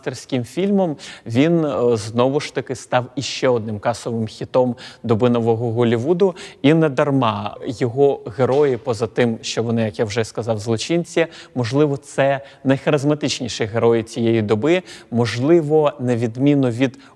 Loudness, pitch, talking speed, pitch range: -19 LUFS, 130 Hz, 130 wpm, 115-150 Hz